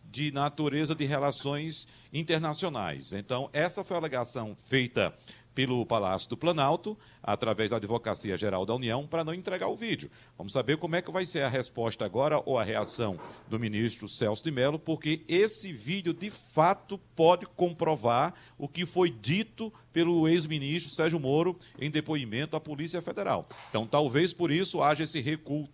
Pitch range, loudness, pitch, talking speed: 125-170 Hz, -30 LUFS, 150 Hz, 165 wpm